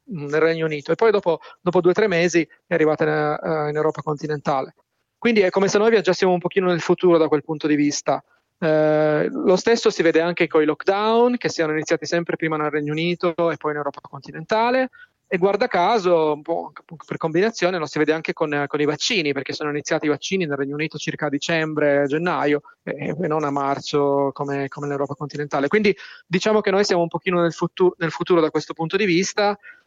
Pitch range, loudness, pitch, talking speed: 150-185 Hz, -21 LUFS, 165 Hz, 210 wpm